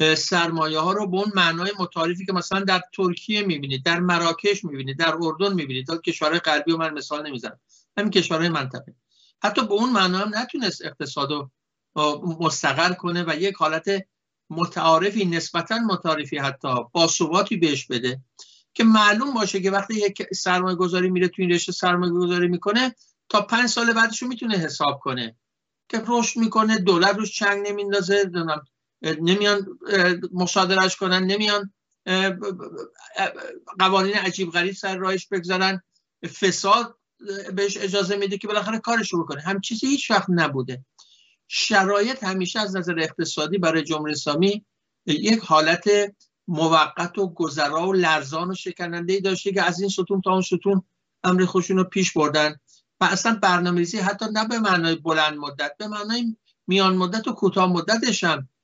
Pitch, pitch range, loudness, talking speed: 185 Hz, 165-200 Hz, -22 LUFS, 150 wpm